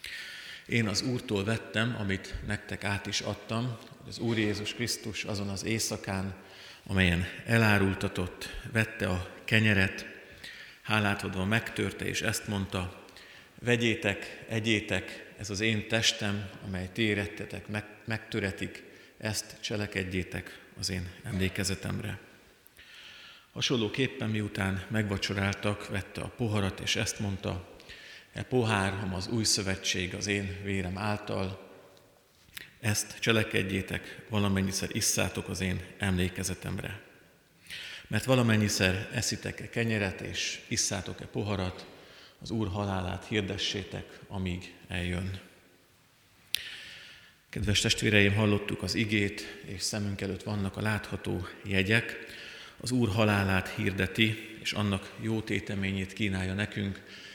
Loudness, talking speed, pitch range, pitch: -31 LUFS, 105 wpm, 95-110 Hz, 100 Hz